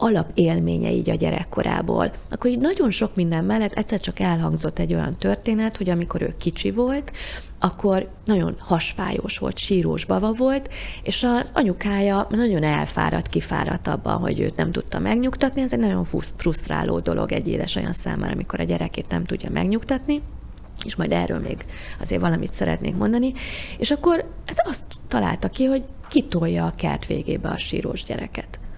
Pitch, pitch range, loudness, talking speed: 200 Hz, 160-245 Hz, -23 LUFS, 160 wpm